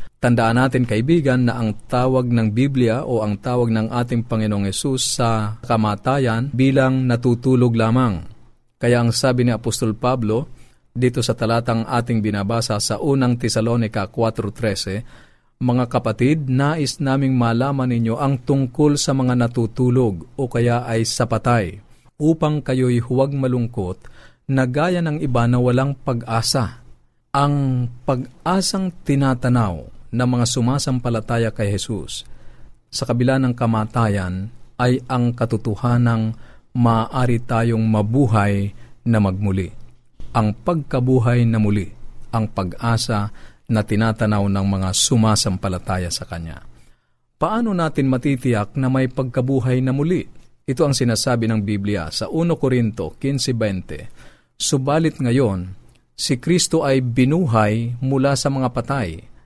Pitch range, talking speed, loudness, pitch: 110-130 Hz, 120 wpm, -19 LUFS, 120 Hz